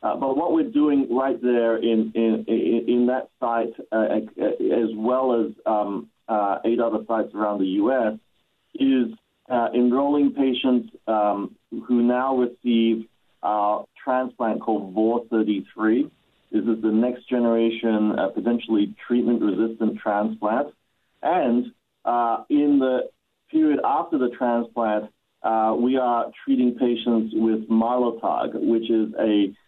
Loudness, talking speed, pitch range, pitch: -23 LUFS, 135 wpm, 110-125 Hz, 115 Hz